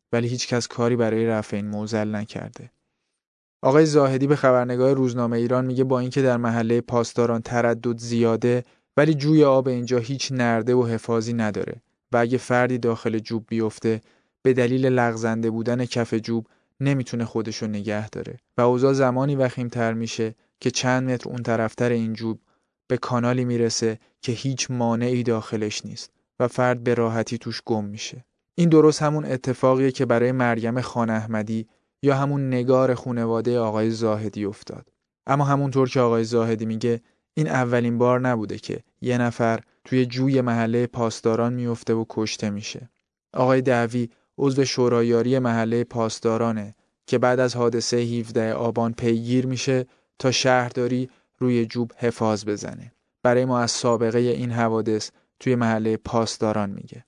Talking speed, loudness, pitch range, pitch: 150 wpm, -23 LUFS, 115-125 Hz, 120 Hz